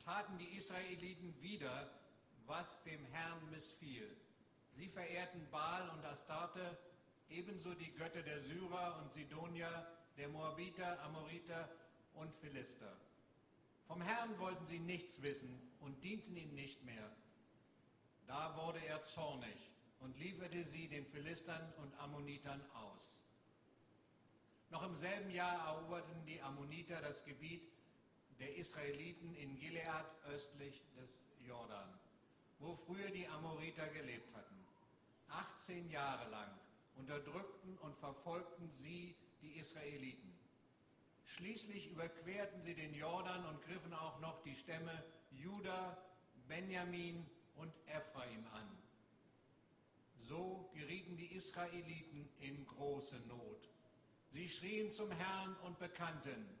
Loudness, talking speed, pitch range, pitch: -51 LUFS, 115 wpm, 145-180 Hz, 165 Hz